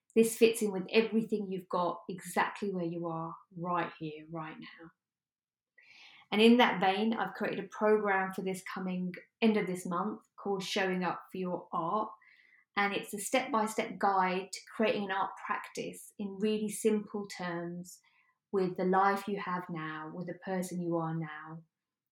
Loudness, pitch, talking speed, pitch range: -33 LUFS, 190 Hz, 175 wpm, 175-215 Hz